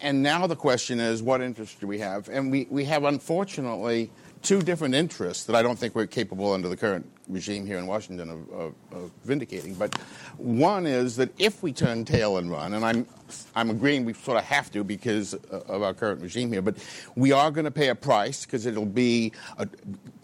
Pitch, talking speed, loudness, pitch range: 120 Hz, 215 wpm, -26 LUFS, 105-140 Hz